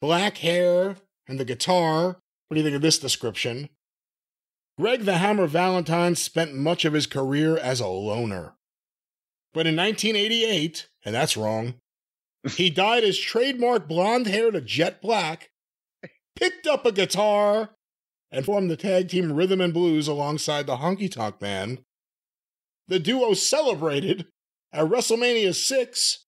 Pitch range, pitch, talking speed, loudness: 150-205 Hz, 175 Hz, 145 wpm, -23 LUFS